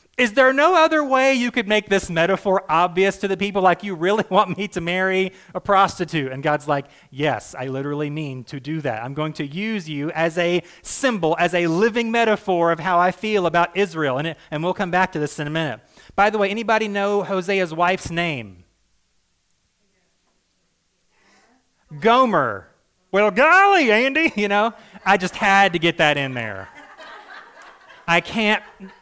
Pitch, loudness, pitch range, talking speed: 185 Hz, -19 LUFS, 155-210 Hz, 180 wpm